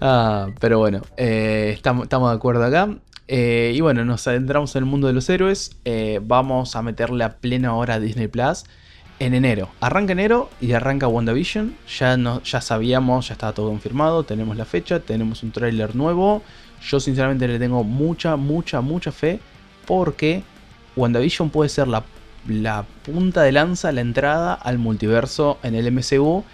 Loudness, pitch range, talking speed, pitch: -20 LUFS, 115-145 Hz, 170 wpm, 125 Hz